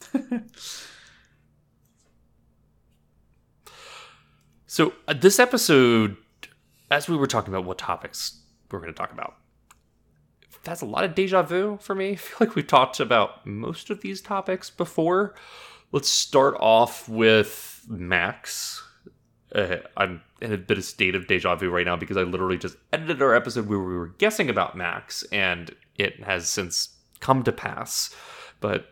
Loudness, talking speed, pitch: -24 LUFS, 150 wpm, 130 Hz